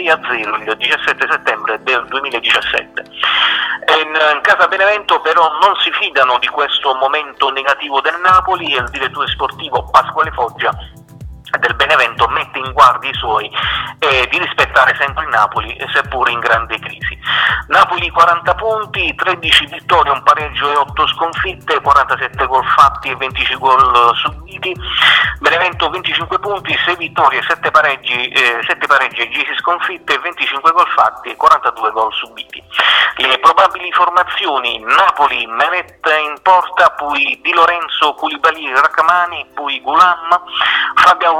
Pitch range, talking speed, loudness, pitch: 145-180 Hz, 140 wpm, -12 LUFS, 165 Hz